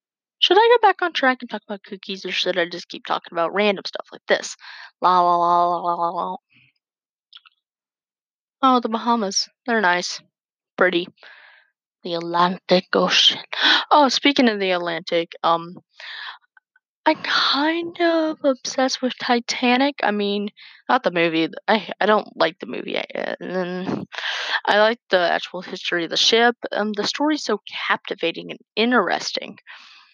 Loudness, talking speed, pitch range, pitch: -20 LUFS, 155 wpm, 180-260 Hz, 210 Hz